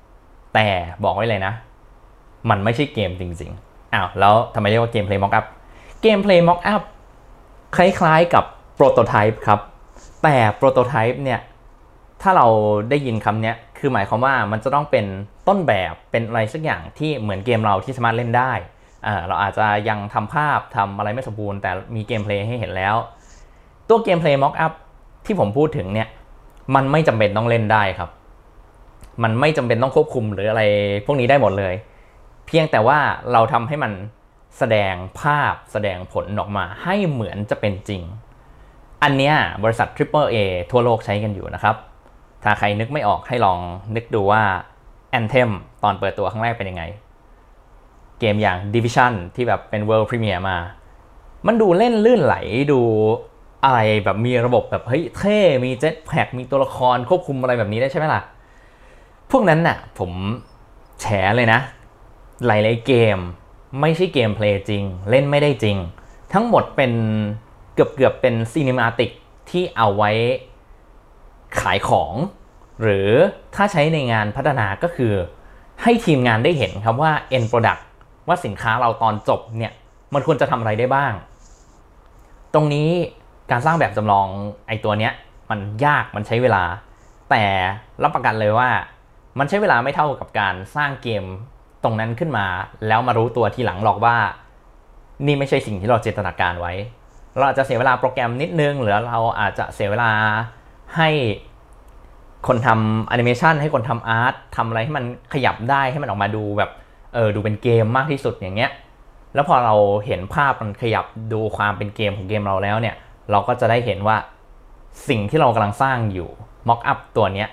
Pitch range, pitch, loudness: 105-130 Hz, 115 Hz, -19 LUFS